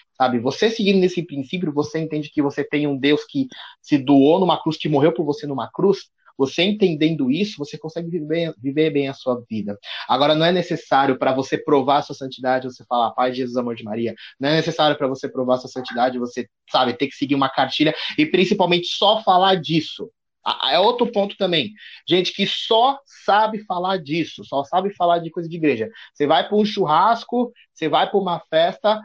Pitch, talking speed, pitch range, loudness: 155 Hz, 200 wpm, 140-185 Hz, -20 LUFS